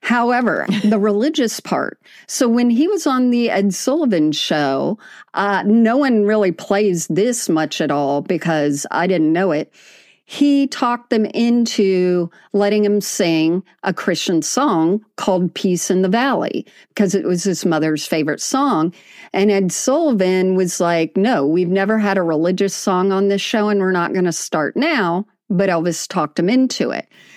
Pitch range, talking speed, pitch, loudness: 175-225 Hz, 170 wpm, 195 Hz, -17 LUFS